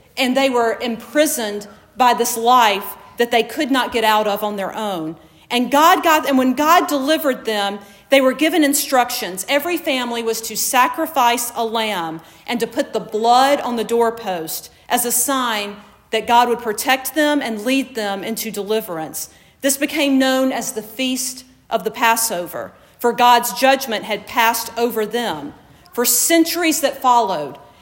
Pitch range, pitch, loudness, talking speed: 220-265 Hz, 240 Hz, -17 LUFS, 165 wpm